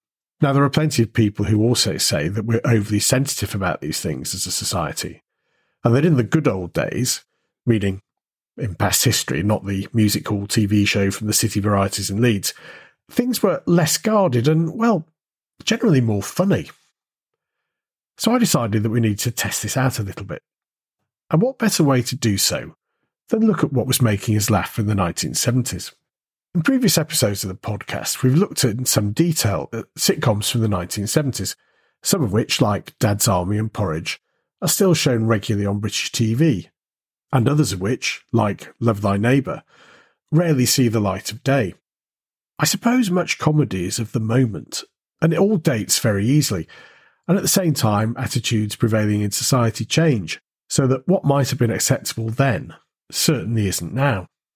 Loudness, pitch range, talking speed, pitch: -19 LUFS, 105-150 Hz, 180 wpm, 115 Hz